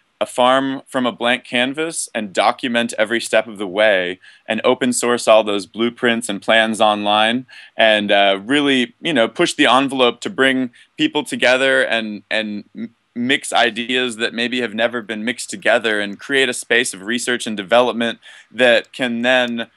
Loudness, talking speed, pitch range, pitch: -17 LUFS, 175 wpm, 110-125 Hz, 120 Hz